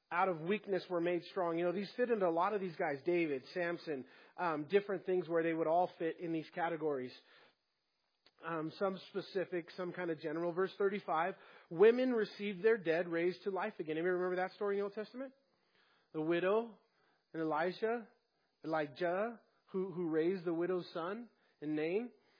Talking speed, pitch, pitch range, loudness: 180 wpm, 180 Hz, 165-200 Hz, -37 LUFS